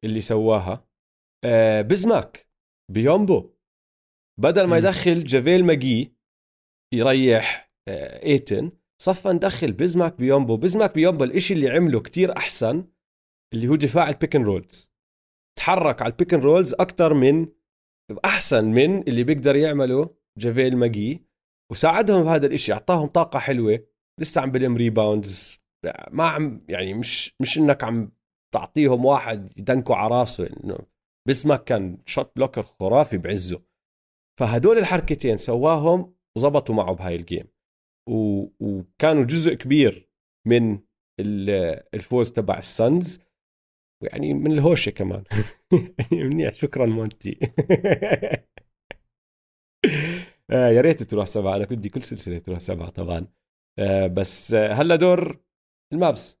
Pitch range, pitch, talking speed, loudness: 100-155 Hz, 120 Hz, 110 wpm, -21 LUFS